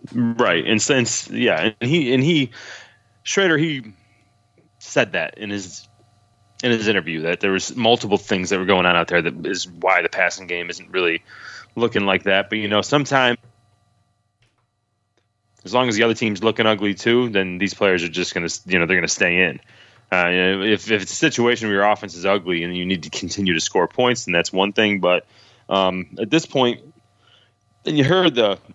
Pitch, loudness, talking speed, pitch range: 105 Hz, -19 LUFS, 205 wpm, 95-120 Hz